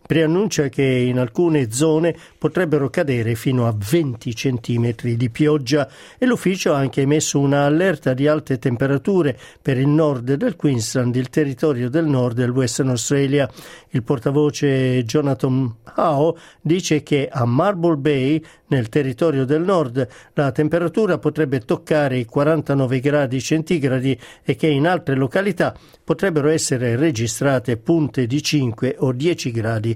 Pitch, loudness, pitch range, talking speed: 145 Hz, -19 LUFS, 130-160 Hz, 140 wpm